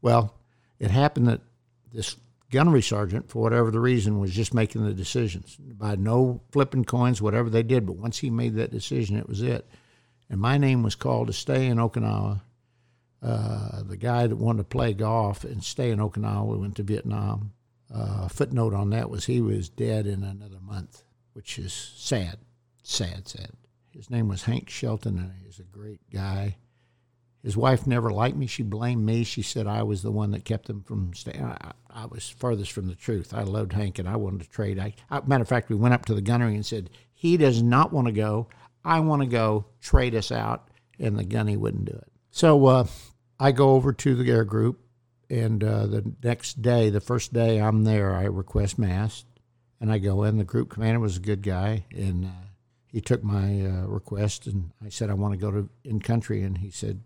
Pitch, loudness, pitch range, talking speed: 110 Hz, -26 LUFS, 105-120 Hz, 215 wpm